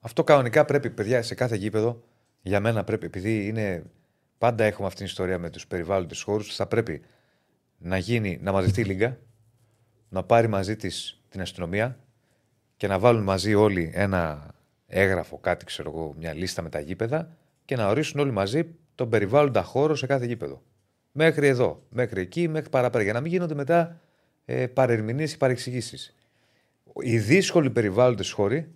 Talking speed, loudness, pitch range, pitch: 165 wpm, -25 LUFS, 95-130 Hz, 115 Hz